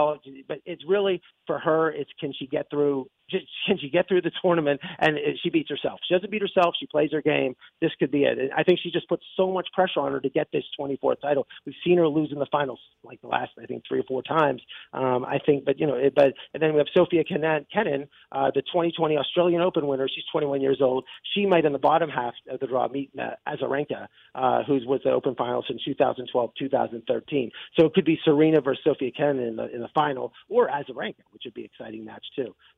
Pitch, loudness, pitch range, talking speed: 150 Hz, -25 LUFS, 140-175 Hz, 235 wpm